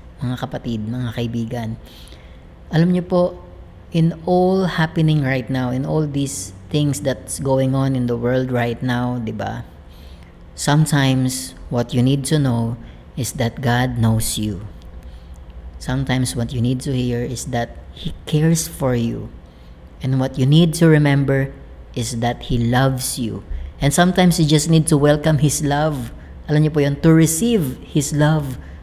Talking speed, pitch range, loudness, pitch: 160 wpm, 110-150 Hz, -19 LUFS, 125 Hz